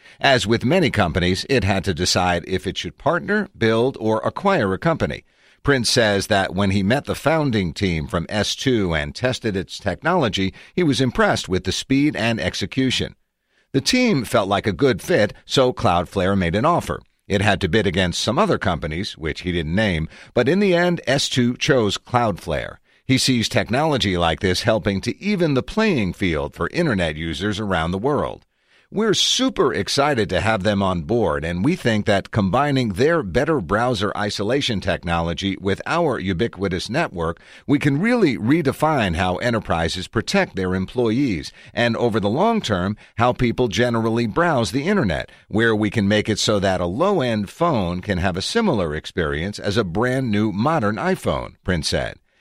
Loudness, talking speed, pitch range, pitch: -20 LUFS, 175 wpm, 95-125 Hz, 105 Hz